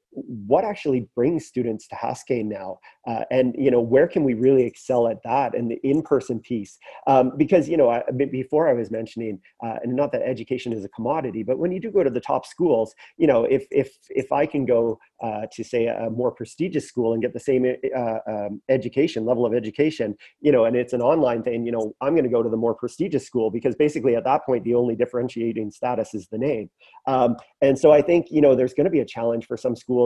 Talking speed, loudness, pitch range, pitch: 240 wpm, -22 LUFS, 115-135 Hz, 125 Hz